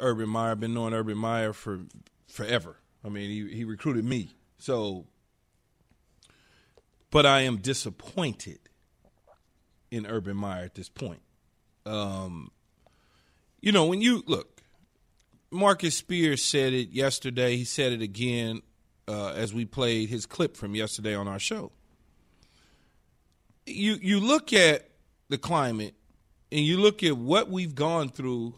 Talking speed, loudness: 135 wpm, -27 LUFS